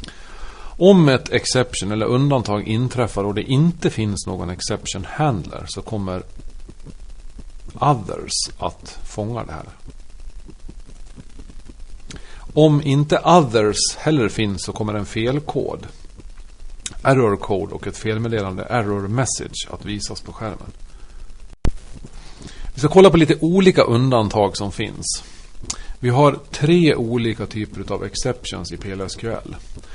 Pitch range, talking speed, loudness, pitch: 95-130 Hz, 115 wpm, -19 LUFS, 110 Hz